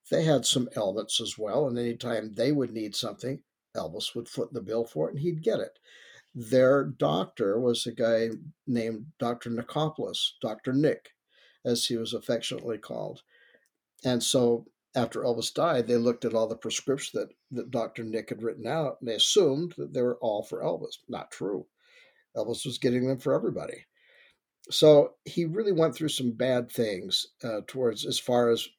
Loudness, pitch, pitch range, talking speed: -28 LUFS, 125 Hz, 115-150 Hz, 180 wpm